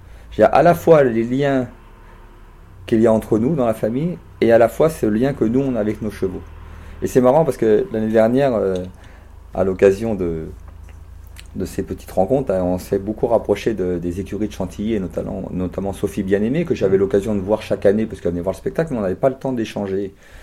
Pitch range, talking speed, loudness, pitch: 90-110 Hz, 225 wpm, -19 LUFS, 100 Hz